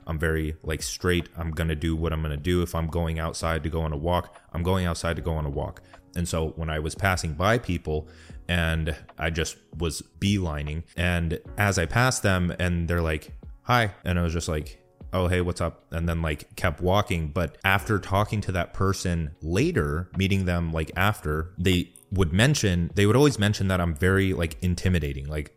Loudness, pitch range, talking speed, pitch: -26 LUFS, 80-95 Hz, 210 wpm, 85 Hz